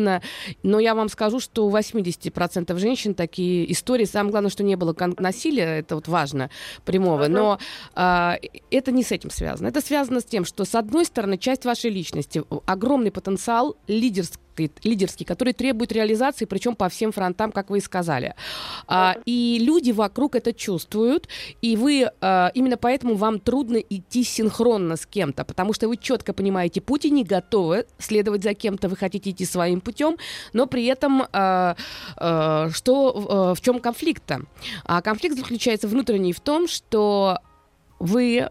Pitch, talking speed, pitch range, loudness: 215 Hz, 160 wpm, 185-245 Hz, -23 LUFS